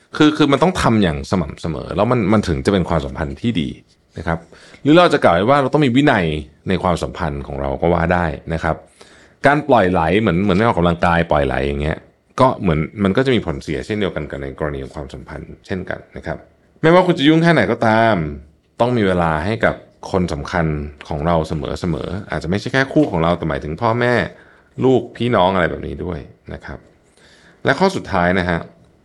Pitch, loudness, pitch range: 85 Hz, -17 LUFS, 75-115 Hz